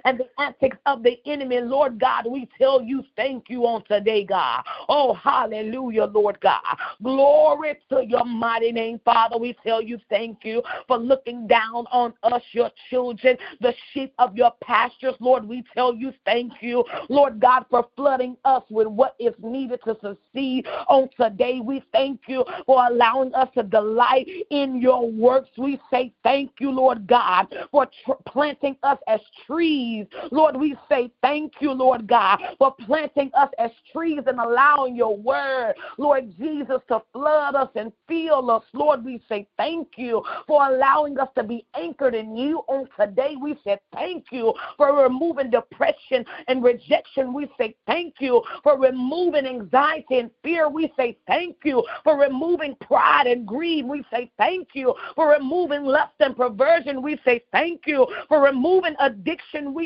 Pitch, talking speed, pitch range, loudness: 260 Hz, 170 wpm, 240-290 Hz, -21 LUFS